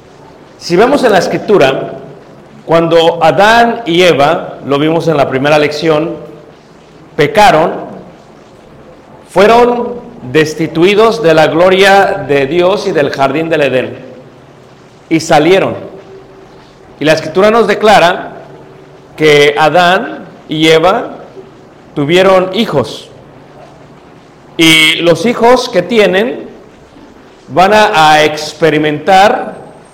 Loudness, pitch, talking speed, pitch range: -8 LUFS, 160 Hz, 100 wpm, 150-195 Hz